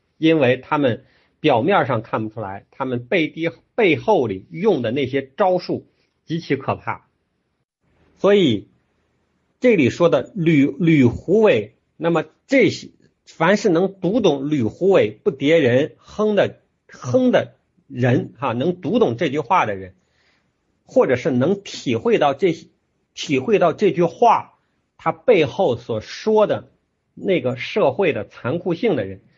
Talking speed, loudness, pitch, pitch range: 200 characters per minute, -19 LUFS, 165 Hz, 130-195 Hz